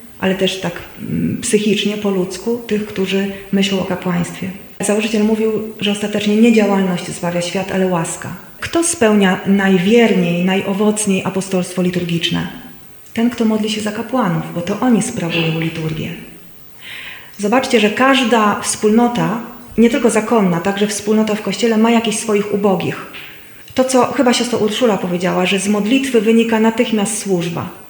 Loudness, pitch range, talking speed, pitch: -16 LUFS, 190-225 Hz, 140 wpm, 205 Hz